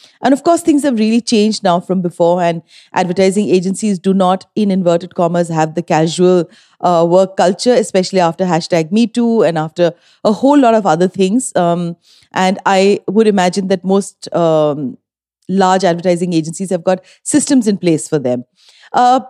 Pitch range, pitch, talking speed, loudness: 175-210 Hz, 185 Hz, 170 wpm, -13 LUFS